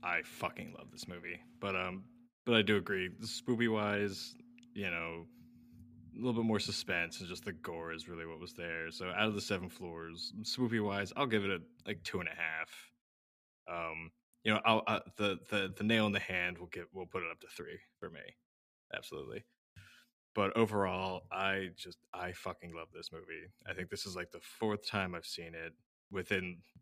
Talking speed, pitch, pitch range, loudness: 205 wpm, 95 Hz, 85-110 Hz, -37 LUFS